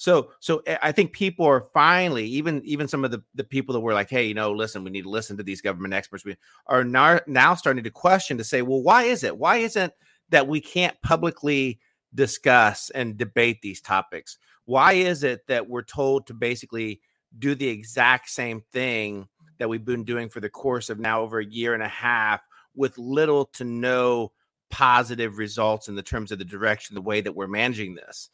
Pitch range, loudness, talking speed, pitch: 110-140 Hz, -23 LUFS, 210 wpm, 120 Hz